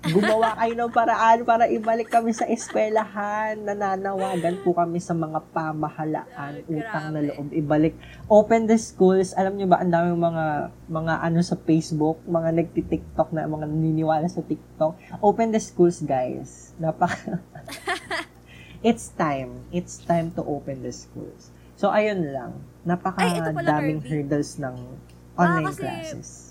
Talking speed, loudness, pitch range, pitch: 140 wpm, -24 LUFS, 155-195 Hz, 165 Hz